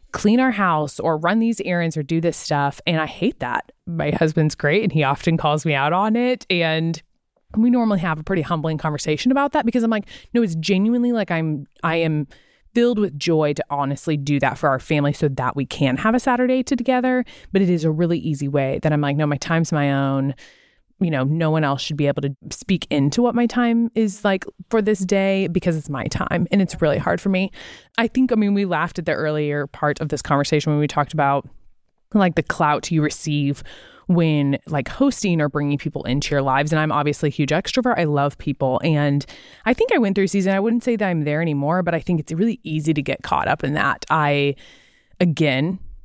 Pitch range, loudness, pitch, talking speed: 145-195 Hz, -20 LUFS, 160 Hz, 230 wpm